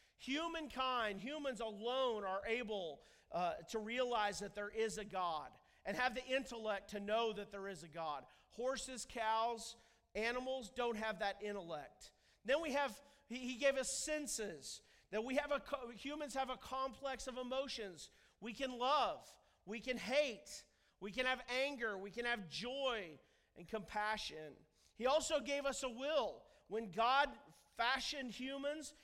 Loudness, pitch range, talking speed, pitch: -41 LUFS, 215-270 Hz, 150 wpm, 245 Hz